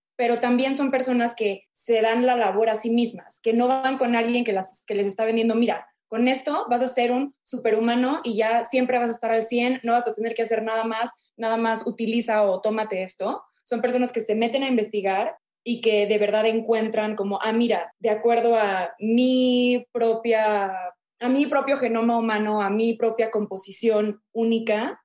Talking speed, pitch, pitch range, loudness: 200 wpm, 230 Hz, 215-240 Hz, -23 LUFS